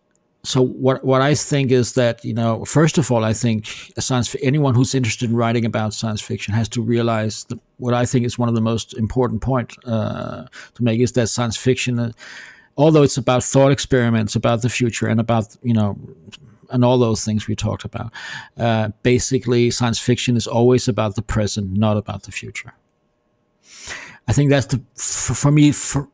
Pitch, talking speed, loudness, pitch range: 120 Hz, 200 wpm, -19 LUFS, 110-130 Hz